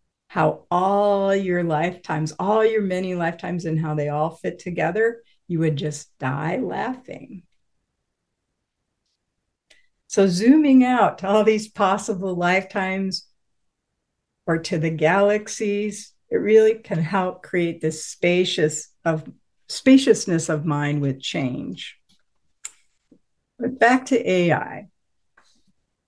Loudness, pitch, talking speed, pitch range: -21 LUFS, 185 Hz, 110 wpm, 160-215 Hz